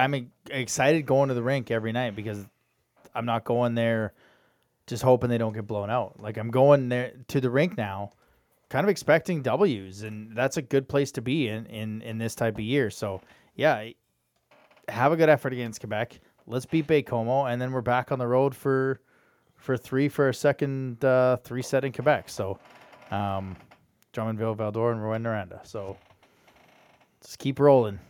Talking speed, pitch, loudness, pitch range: 185 wpm, 125 Hz, -26 LUFS, 110-135 Hz